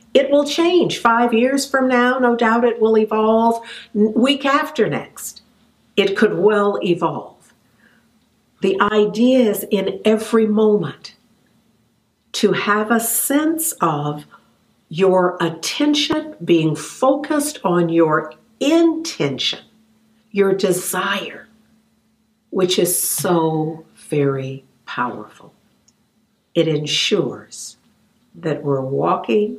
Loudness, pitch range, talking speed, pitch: -17 LUFS, 175-235 Hz, 100 wpm, 215 Hz